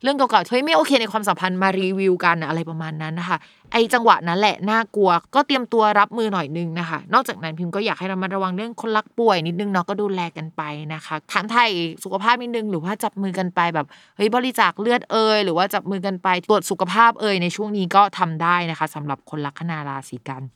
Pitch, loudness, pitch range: 190 Hz, -20 LUFS, 170-220 Hz